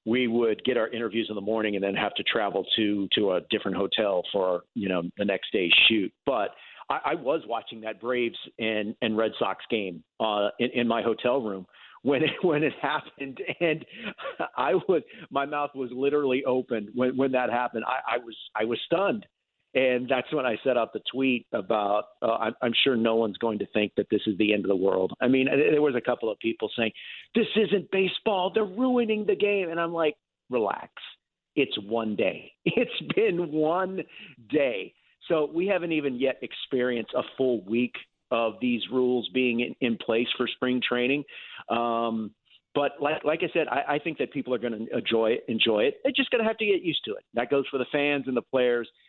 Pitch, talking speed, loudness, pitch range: 125 Hz, 210 wpm, -27 LUFS, 115-150 Hz